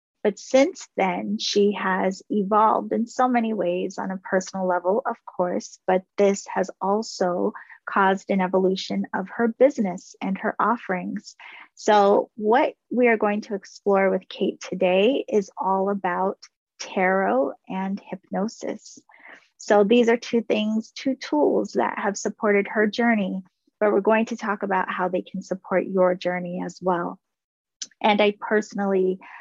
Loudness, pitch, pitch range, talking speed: -23 LUFS, 200 Hz, 185-220 Hz, 150 wpm